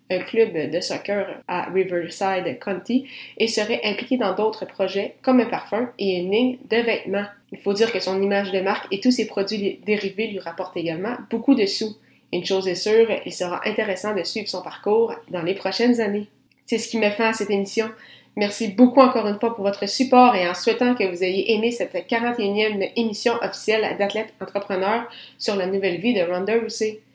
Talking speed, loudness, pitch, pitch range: 200 wpm, -22 LUFS, 210 Hz, 190-230 Hz